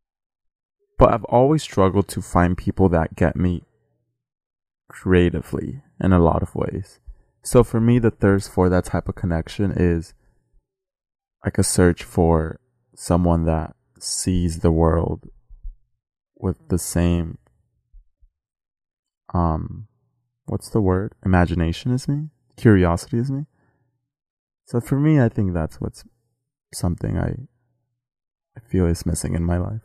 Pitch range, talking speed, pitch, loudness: 85-120 Hz, 130 wpm, 95 Hz, -21 LUFS